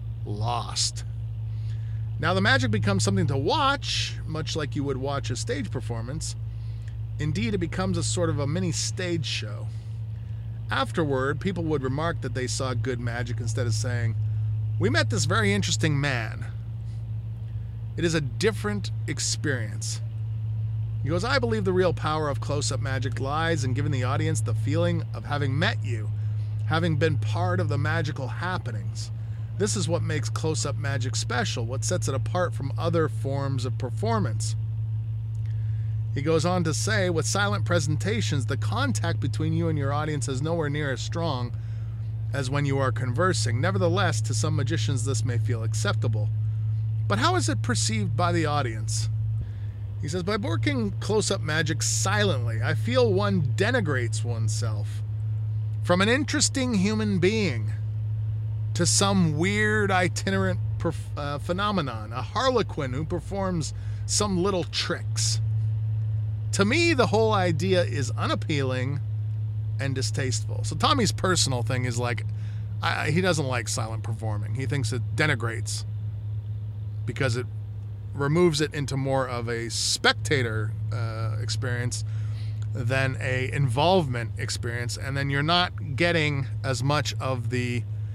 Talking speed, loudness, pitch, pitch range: 145 wpm, -26 LUFS, 110 Hz, 105-120 Hz